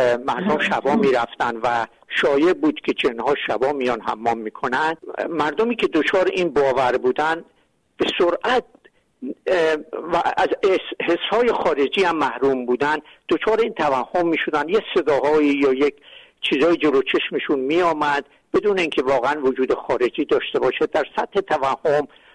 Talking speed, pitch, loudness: 135 wpm, 170 Hz, -20 LUFS